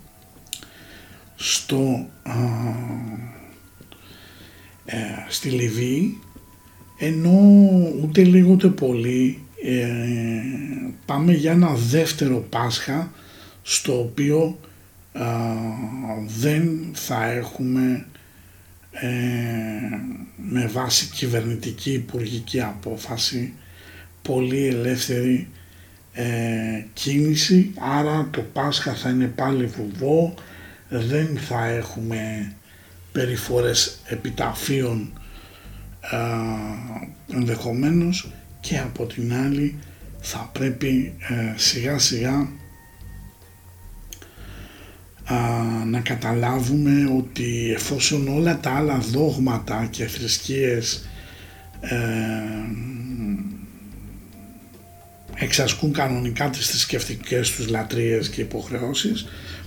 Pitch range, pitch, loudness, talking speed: 100-130 Hz, 115 Hz, -22 LUFS, 75 wpm